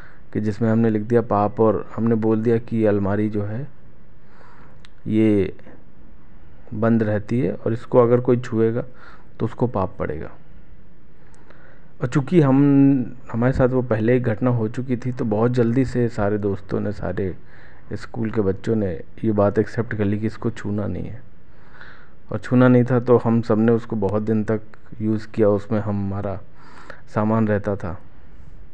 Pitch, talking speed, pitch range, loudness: 110 Hz, 165 wpm, 105-120 Hz, -21 LUFS